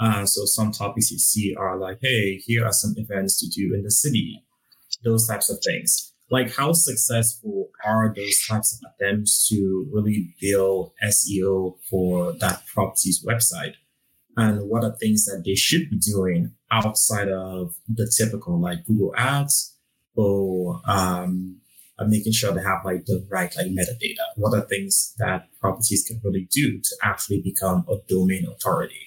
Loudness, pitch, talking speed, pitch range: -22 LUFS, 105 Hz, 165 wpm, 95-115 Hz